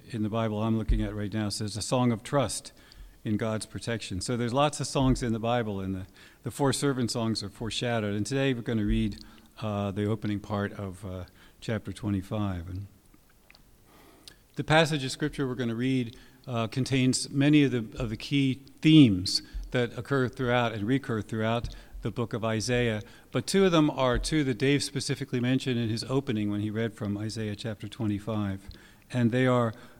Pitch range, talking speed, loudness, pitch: 105-130 Hz, 195 wpm, -28 LUFS, 115 Hz